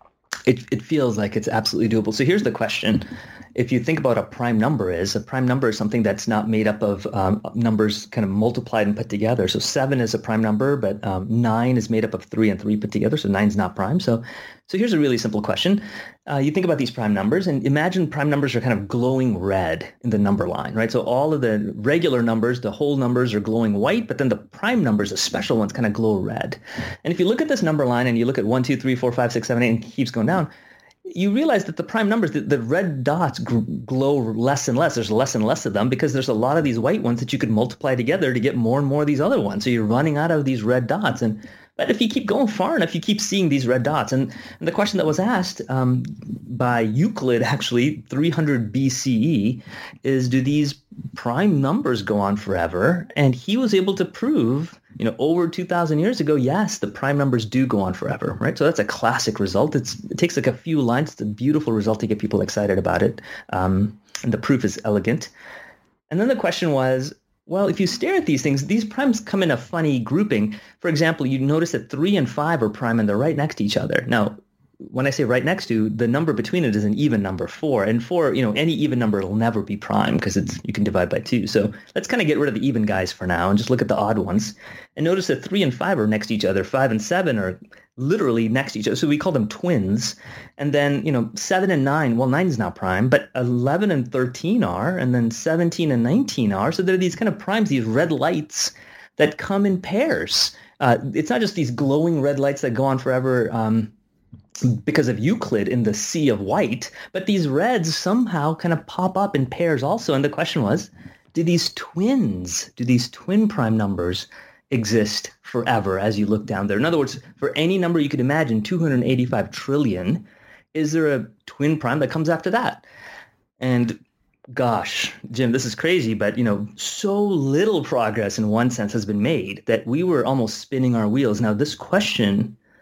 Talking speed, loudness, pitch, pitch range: 235 wpm, -21 LUFS, 130 Hz, 110-160 Hz